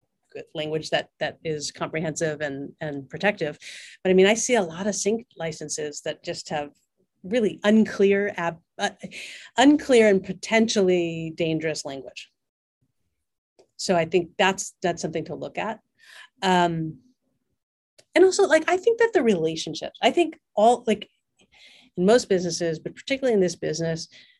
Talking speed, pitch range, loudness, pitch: 145 wpm, 160-220 Hz, -23 LUFS, 180 Hz